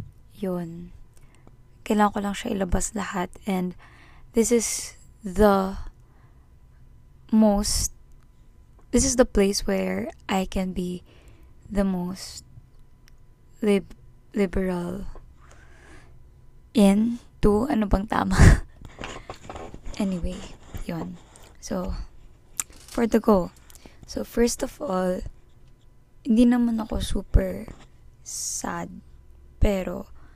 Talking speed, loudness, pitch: 90 wpm, -25 LUFS, 195 Hz